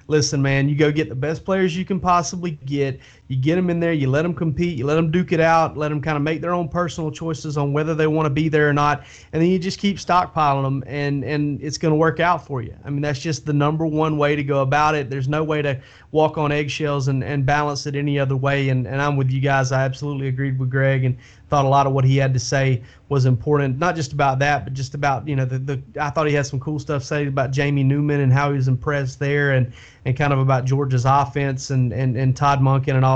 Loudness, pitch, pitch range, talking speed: -20 LUFS, 145 Hz, 135-155 Hz, 275 wpm